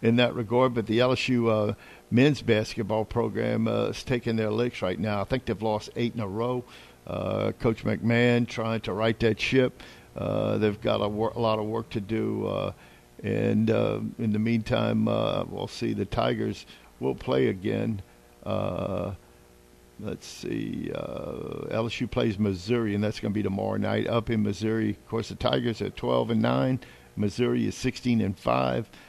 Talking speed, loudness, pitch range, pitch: 180 wpm, -27 LUFS, 105-120 Hz, 110 Hz